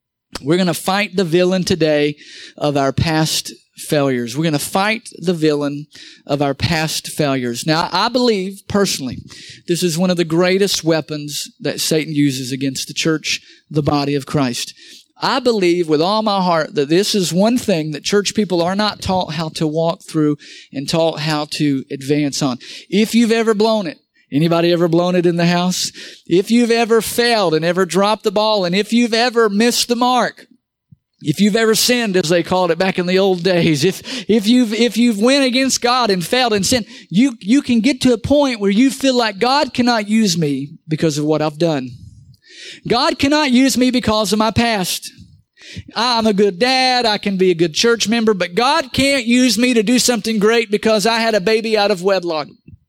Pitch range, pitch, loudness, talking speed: 155-230 Hz, 190 Hz, -16 LUFS, 200 wpm